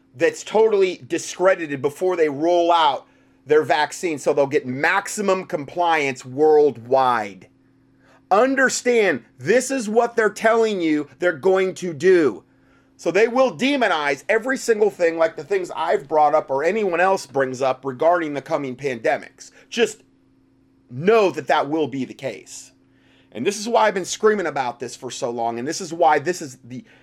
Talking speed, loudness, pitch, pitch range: 165 wpm, -20 LUFS, 170 Hz, 140-215 Hz